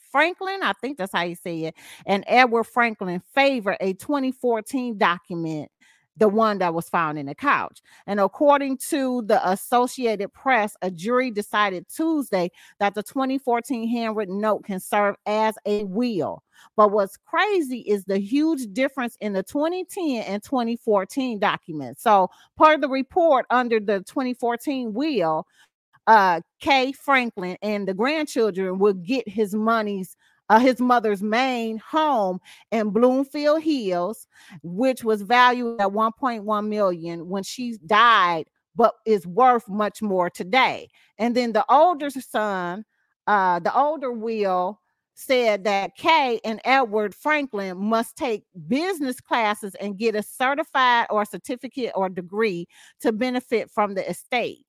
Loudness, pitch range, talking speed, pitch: -22 LUFS, 195-255 Hz, 145 wpm, 220 Hz